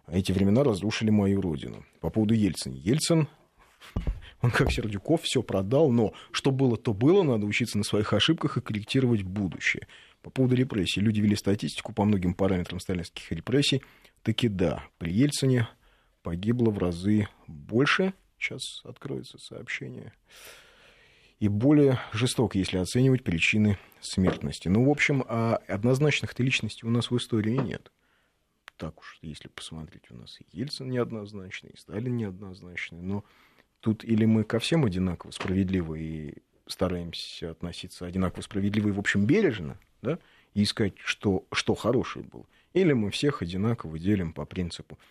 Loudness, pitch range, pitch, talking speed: -27 LUFS, 95-125 Hz, 105 Hz, 145 wpm